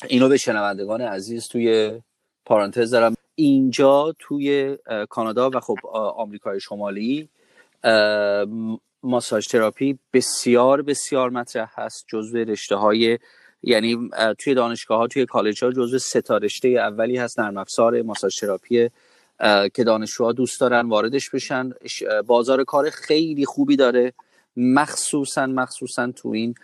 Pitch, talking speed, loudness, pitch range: 120 Hz, 125 wpm, -21 LUFS, 110-130 Hz